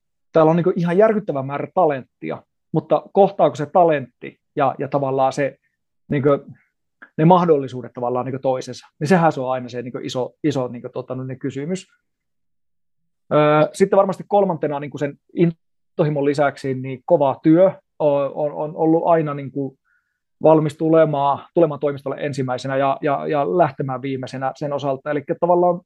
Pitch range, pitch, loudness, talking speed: 135-165 Hz, 145 Hz, -19 LUFS, 140 wpm